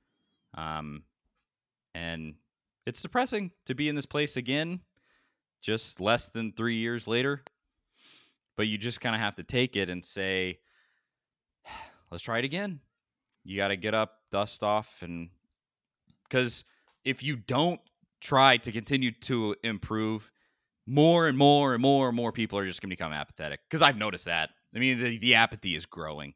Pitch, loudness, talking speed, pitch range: 115 Hz, -28 LUFS, 160 wpm, 100-135 Hz